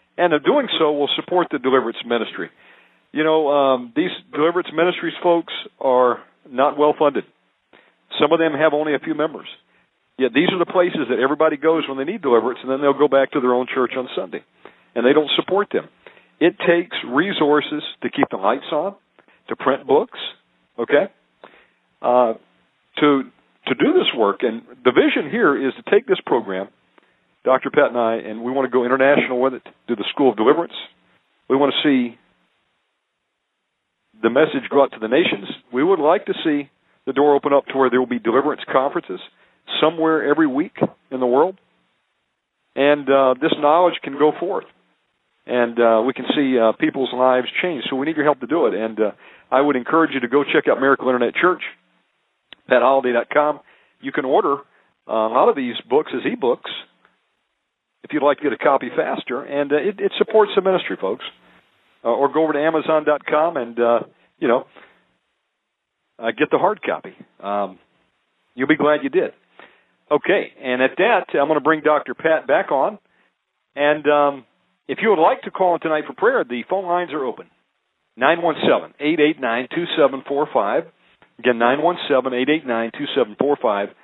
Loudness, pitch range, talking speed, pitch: -19 LUFS, 125-160 Hz, 180 wpm, 145 Hz